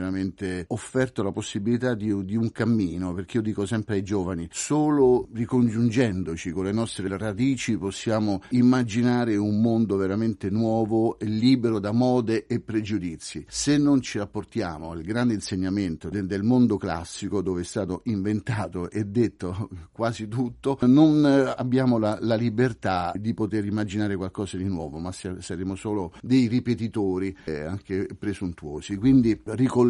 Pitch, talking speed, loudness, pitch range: 105 Hz, 140 wpm, -25 LUFS, 95-120 Hz